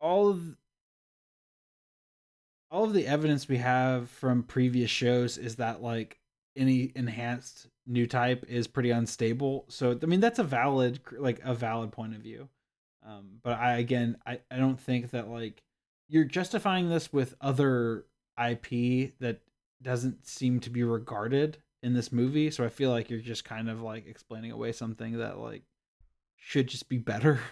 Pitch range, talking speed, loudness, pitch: 115-135 Hz, 165 wpm, -30 LUFS, 125 Hz